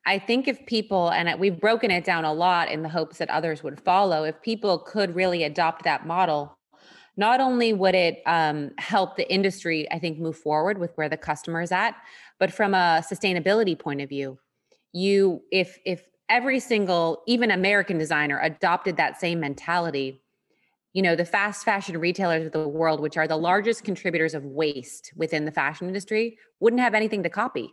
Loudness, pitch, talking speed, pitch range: -24 LUFS, 175 Hz, 190 wpm, 160-200 Hz